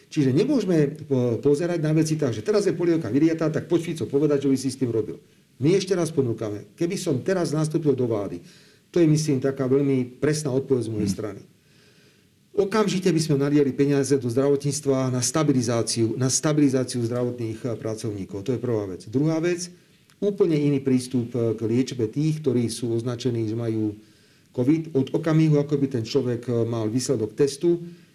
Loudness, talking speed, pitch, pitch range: -23 LUFS, 175 wpm, 135 Hz, 120-155 Hz